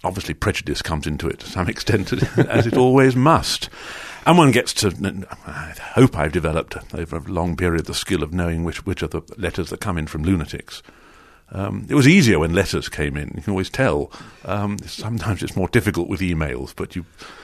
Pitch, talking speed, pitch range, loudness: 90 Hz, 195 wpm, 80-105 Hz, -20 LUFS